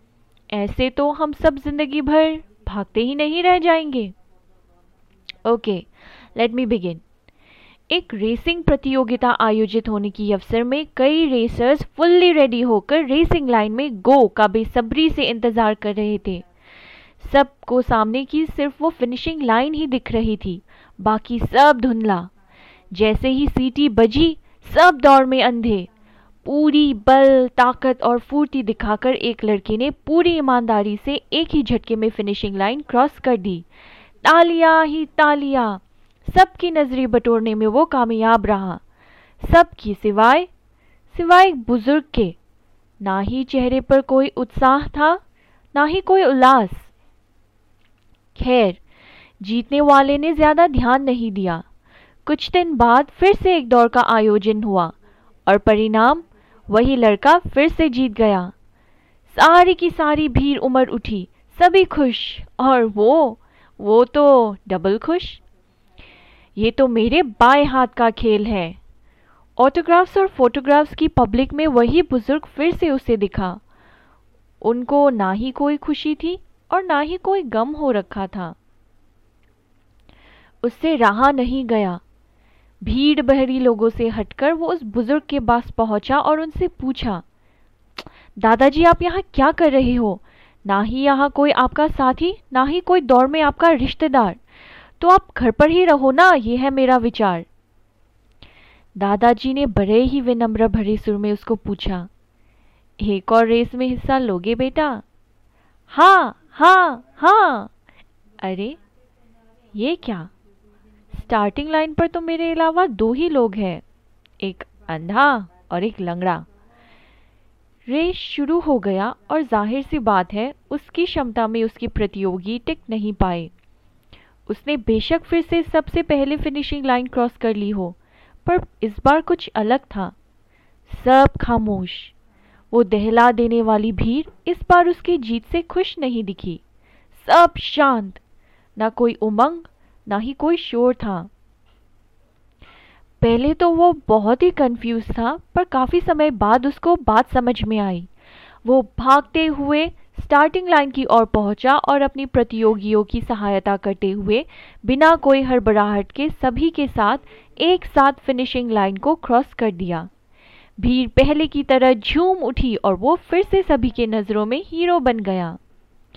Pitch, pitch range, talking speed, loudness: 245 Hz, 205-295 Hz, 140 wpm, -17 LUFS